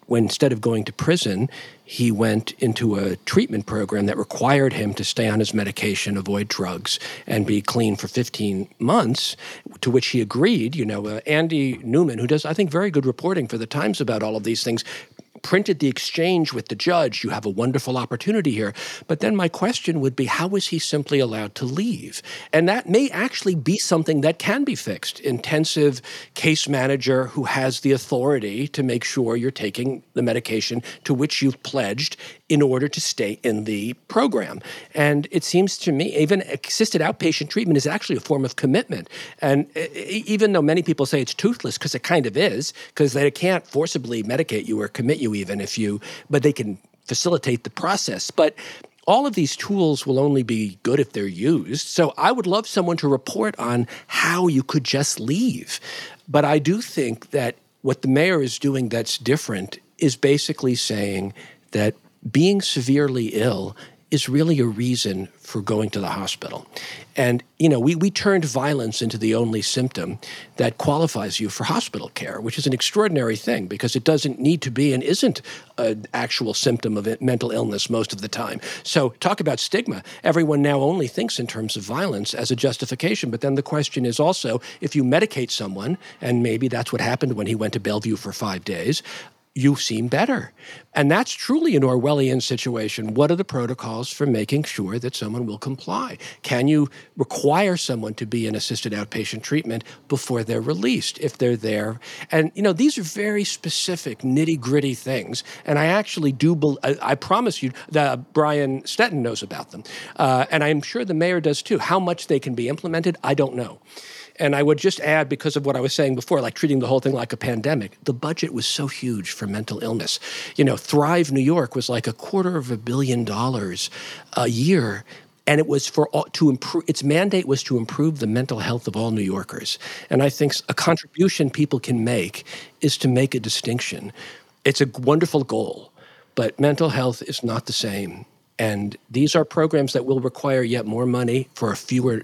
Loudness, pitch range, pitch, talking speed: -22 LUFS, 115-155 Hz, 135 Hz, 195 wpm